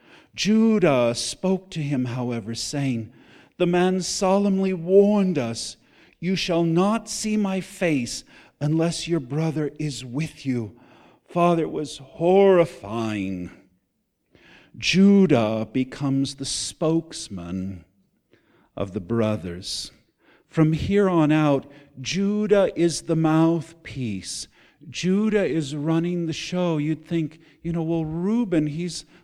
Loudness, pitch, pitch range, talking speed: -23 LUFS, 160 Hz, 130-180 Hz, 110 wpm